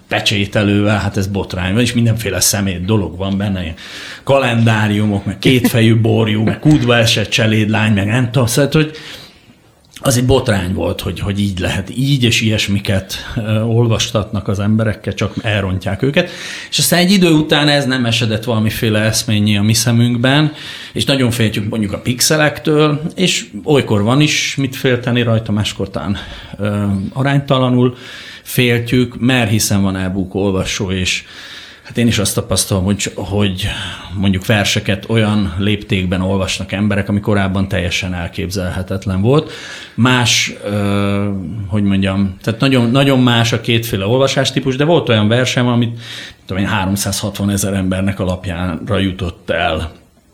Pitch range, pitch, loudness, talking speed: 100-125 Hz, 110 Hz, -15 LUFS, 140 wpm